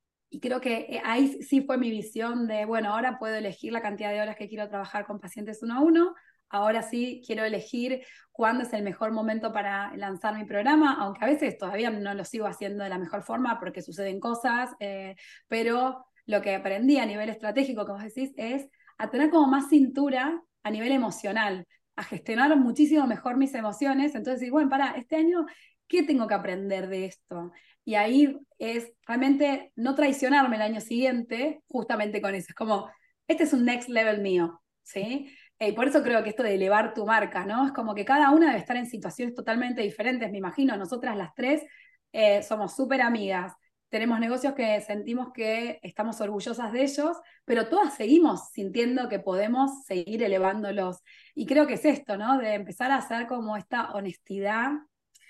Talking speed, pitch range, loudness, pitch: 185 wpm, 205-270 Hz, -27 LUFS, 230 Hz